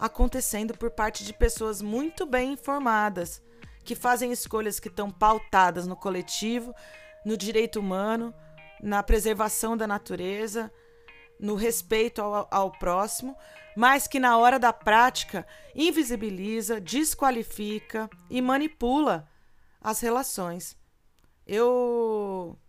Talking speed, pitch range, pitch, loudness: 110 wpm, 210-245 Hz, 220 Hz, -26 LUFS